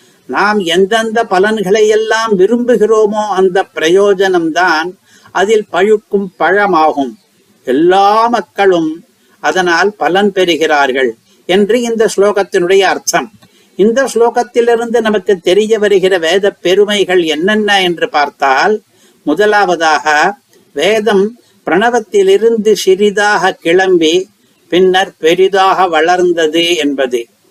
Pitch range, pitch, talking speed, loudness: 180-215 Hz, 195 Hz, 85 wpm, -10 LUFS